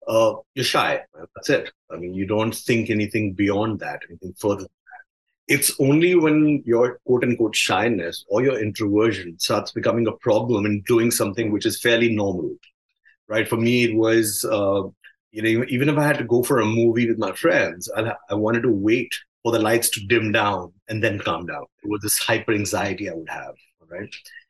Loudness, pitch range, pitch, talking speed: -21 LUFS, 105-120 Hz, 115 Hz, 200 wpm